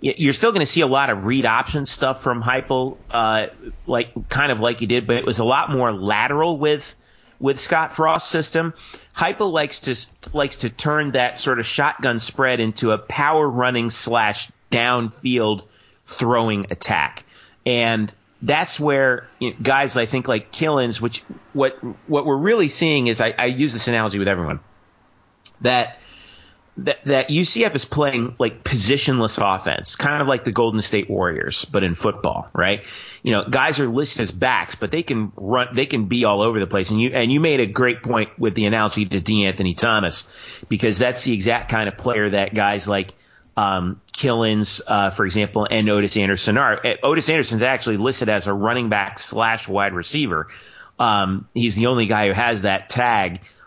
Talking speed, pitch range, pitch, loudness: 185 wpm, 105-135 Hz, 120 Hz, -20 LUFS